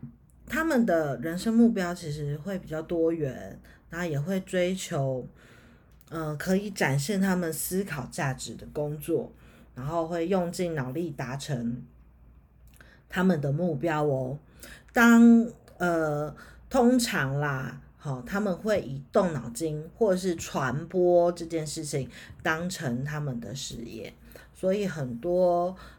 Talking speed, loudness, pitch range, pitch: 190 characters per minute, -27 LUFS, 140-185 Hz, 165 Hz